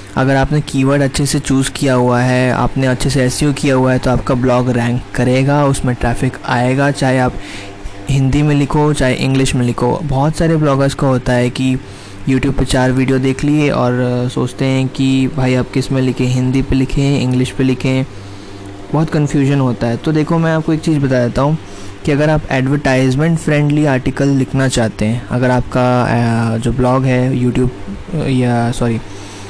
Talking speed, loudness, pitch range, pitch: 185 wpm, -14 LUFS, 125-140 Hz, 130 Hz